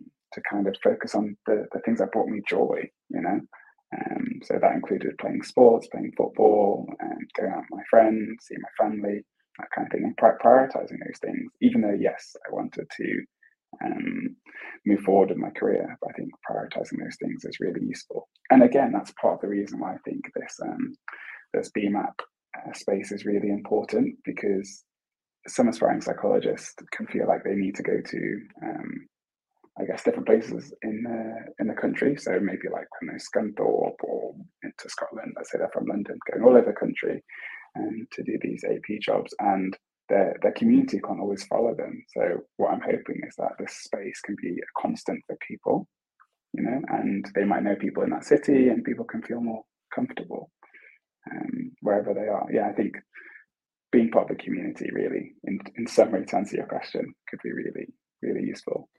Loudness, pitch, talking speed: -26 LUFS, 265 Hz, 195 wpm